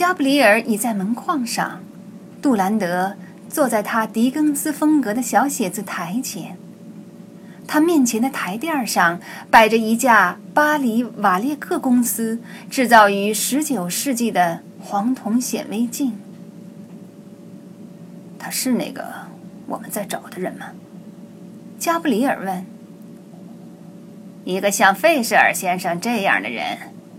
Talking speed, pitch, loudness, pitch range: 190 characters per minute, 205 Hz, -19 LUFS, 195-250 Hz